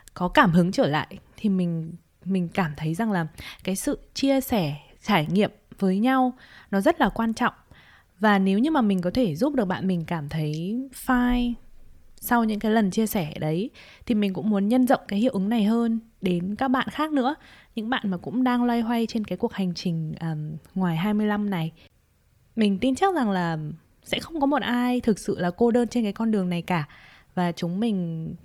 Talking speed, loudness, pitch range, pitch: 215 wpm, -25 LUFS, 180-240 Hz, 205 Hz